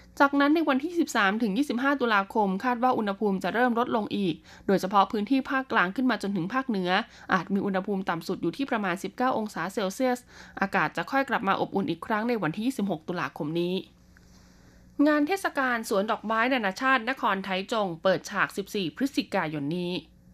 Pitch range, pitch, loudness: 190-255 Hz, 210 Hz, -27 LUFS